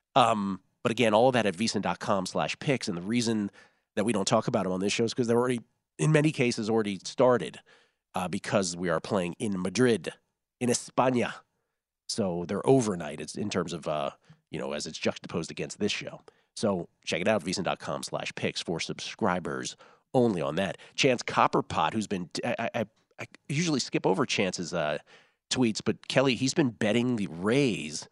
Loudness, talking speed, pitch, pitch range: -29 LUFS, 190 wpm, 115 Hz, 100-125 Hz